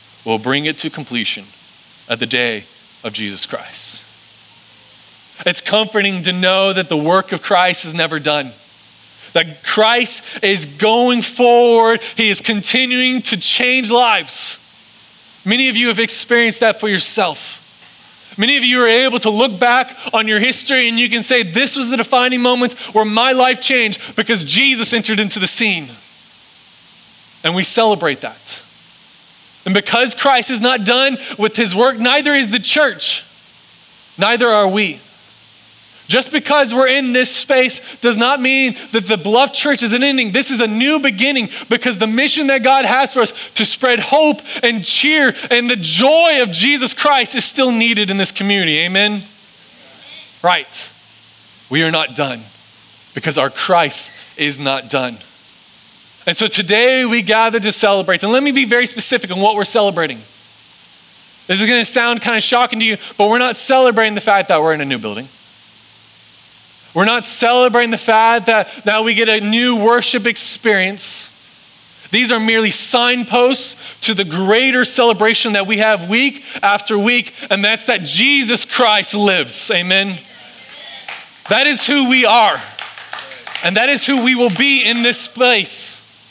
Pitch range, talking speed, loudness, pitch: 195-250 Hz, 165 wpm, -13 LUFS, 230 Hz